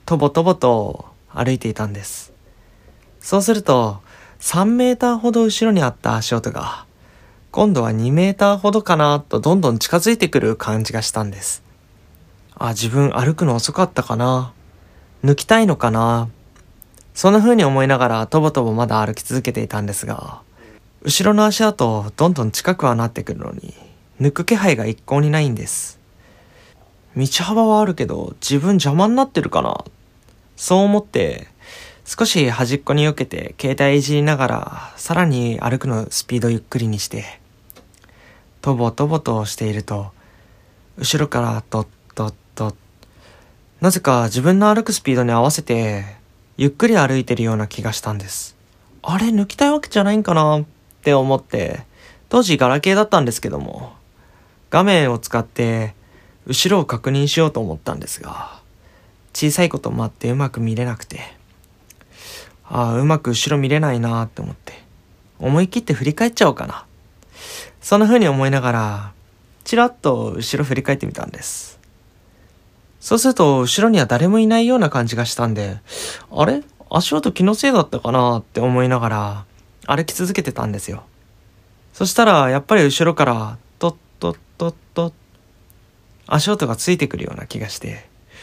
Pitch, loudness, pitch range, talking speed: 125 Hz, -18 LUFS, 110-165 Hz, 320 characters per minute